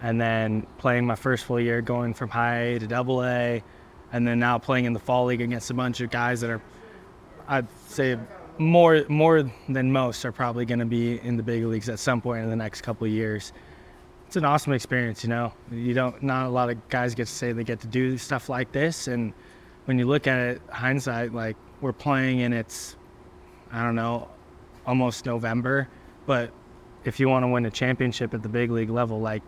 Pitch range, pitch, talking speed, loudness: 115-125 Hz, 120 Hz, 215 wpm, -25 LUFS